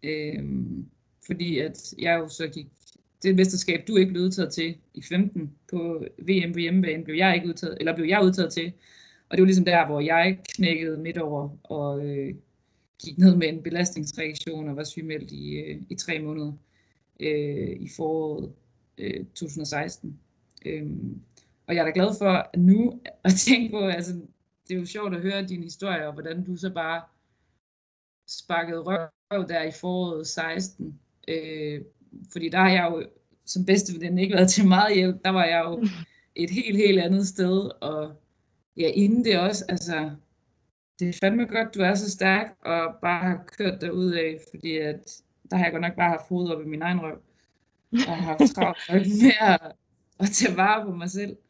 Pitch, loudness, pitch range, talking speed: 170 Hz, -25 LUFS, 155-190 Hz, 190 wpm